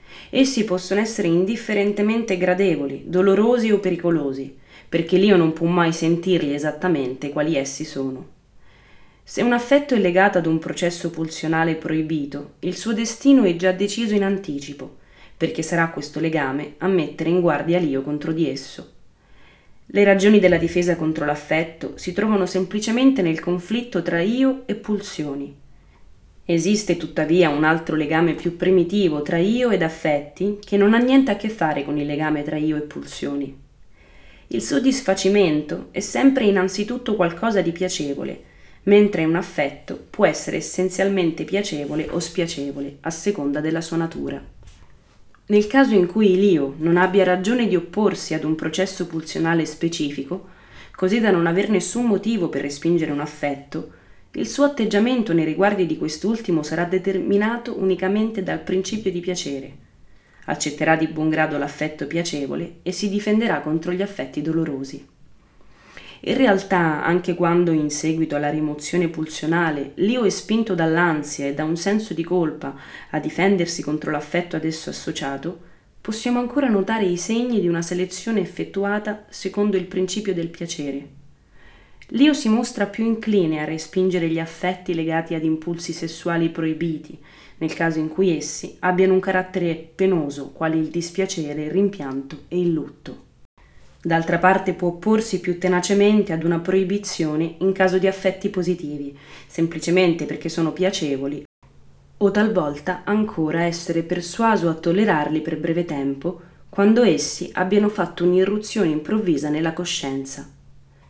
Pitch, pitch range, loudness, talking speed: 170 Hz, 155-195 Hz, -21 LUFS, 145 wpm